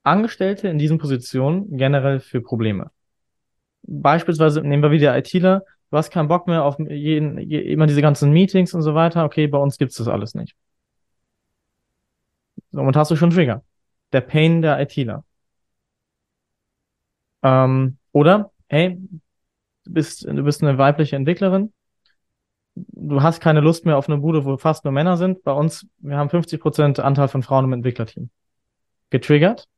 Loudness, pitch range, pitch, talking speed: -18 LUFS, 135-165 Hz, 150 Hz, 155 wpm